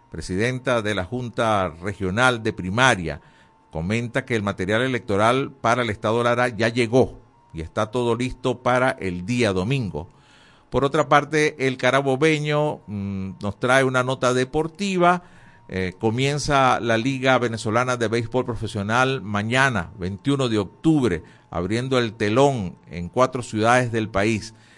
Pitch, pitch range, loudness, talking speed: 120 Hz, 105-130 Hz, -22 LUFS, 140 wpm